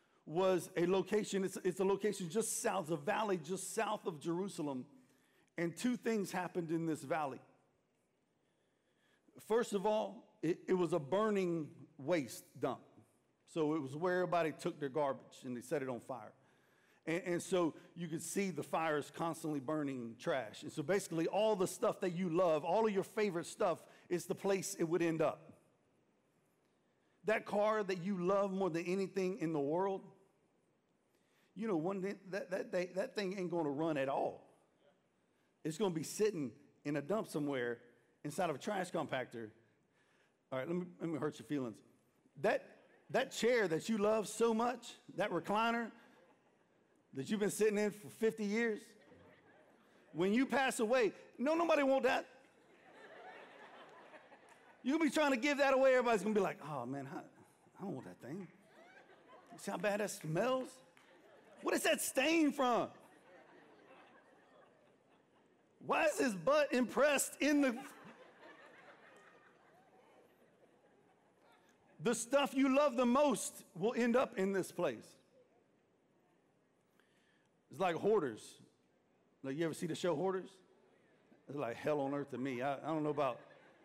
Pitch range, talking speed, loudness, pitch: 160-225 Hz, 160 wpm, -37 LUFS, 190 Hz